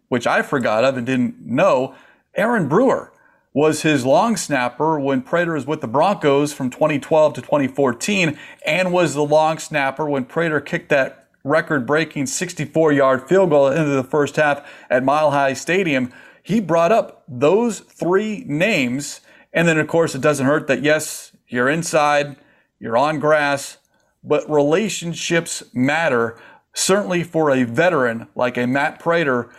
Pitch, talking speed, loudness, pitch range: 150 Hz, 155 wpm, -18 LUFS, 135-170 Hz